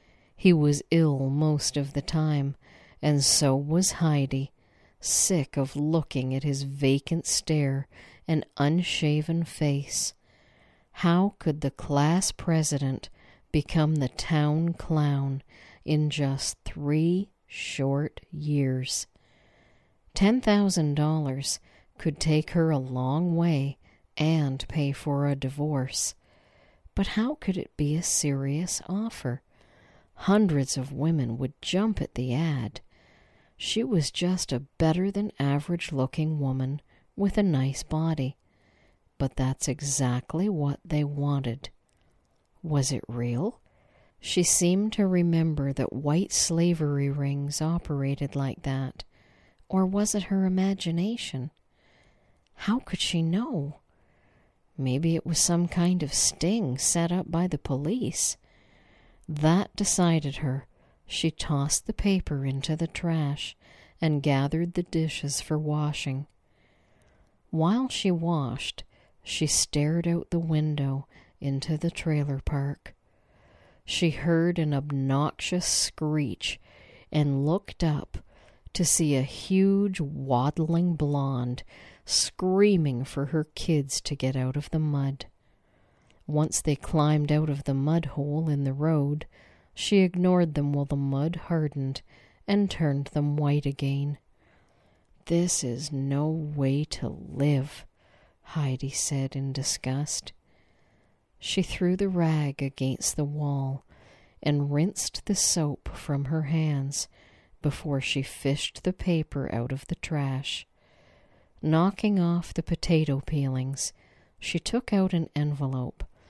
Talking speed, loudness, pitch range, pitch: 120 wpm, -27 LUFS, 135-165 Hz, 145 Hz